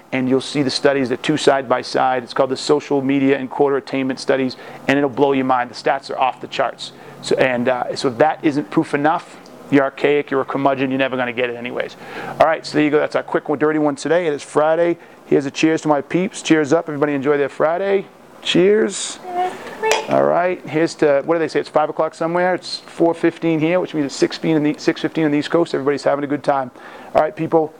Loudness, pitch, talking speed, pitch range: -18 LUFS, 150 Hz, 245 wpm, 135-160 Hz